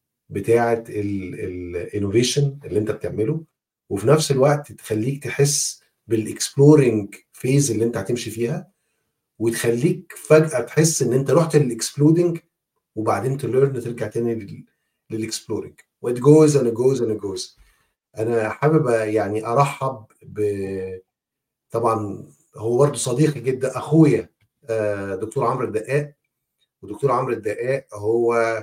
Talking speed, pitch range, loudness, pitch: 110 wpm, 110-145 Hz, -20 LUFS, 120 Hz